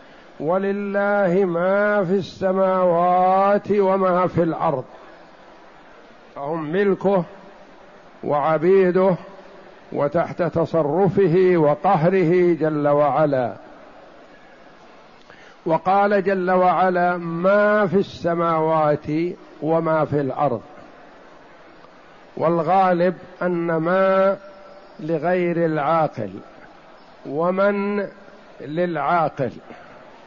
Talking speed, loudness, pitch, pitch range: 60 wpm, -20 LUFS, 180 Hz, 165-195 Hz